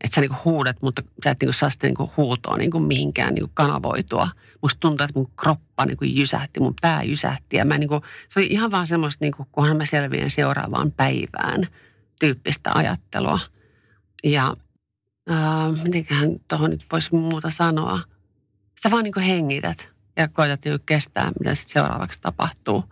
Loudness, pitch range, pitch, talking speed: -22 LUFS, 125-160 Hz, 145 Hz, 160 wpm